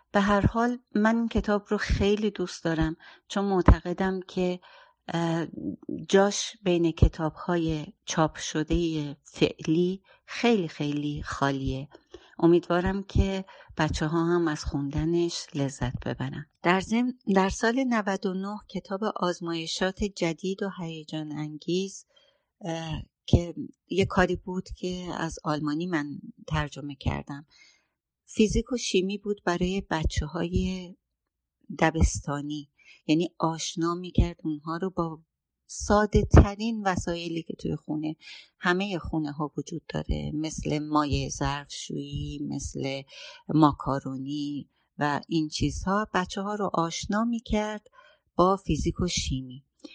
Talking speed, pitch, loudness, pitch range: 115 wpm, 170 Hz, -28 LUFS, 150-195 Hz